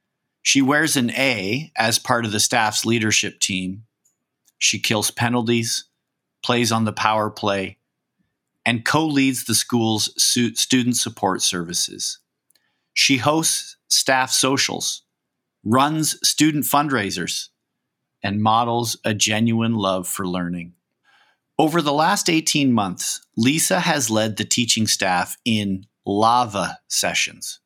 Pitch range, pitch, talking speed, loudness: 105-135 Hz, 115 Hz, 120 wpm, -19 LUFS